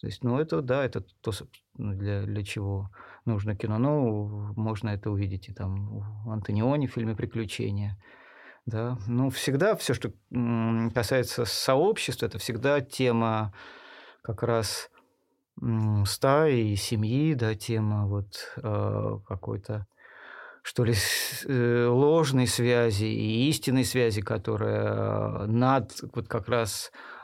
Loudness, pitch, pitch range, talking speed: -28 LUFS, 115 Hz, 105-125 Hz, 120 wpm